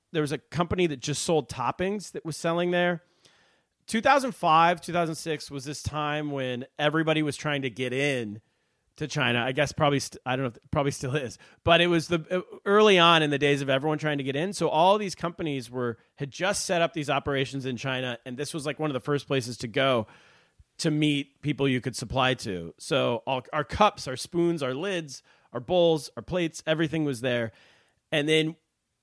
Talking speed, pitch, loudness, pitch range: 205 wpm, 150 Hz, -26 LUFS, 135-170 Hz